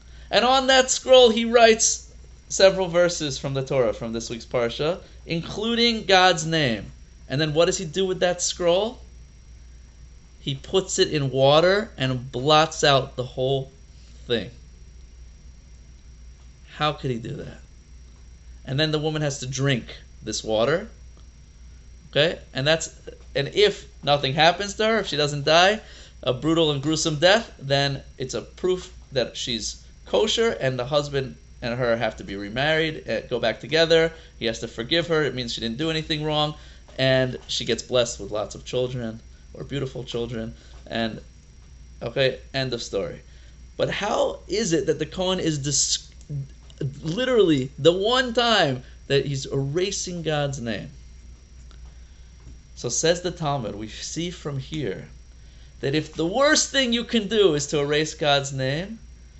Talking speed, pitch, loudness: 160 wpm, 135 Hz, -23 LUFS